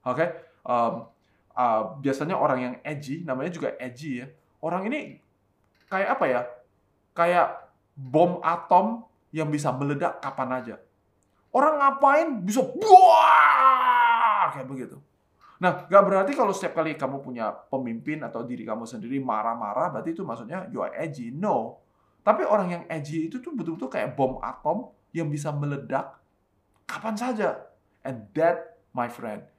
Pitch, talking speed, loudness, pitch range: 150 Hz, 145 wpm, -24 LUFS, 120-180 Hz